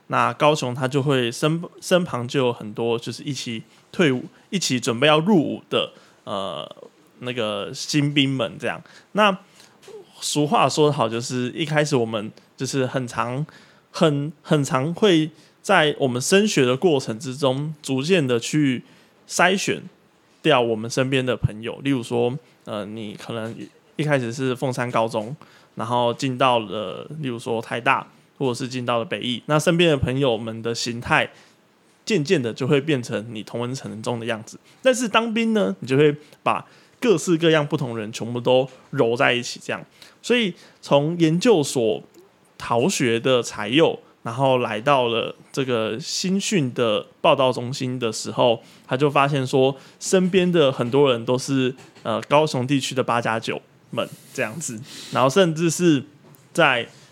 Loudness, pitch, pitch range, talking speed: -22 LUFS, 135 Hz, 120-155 Hz, 235 characters per minute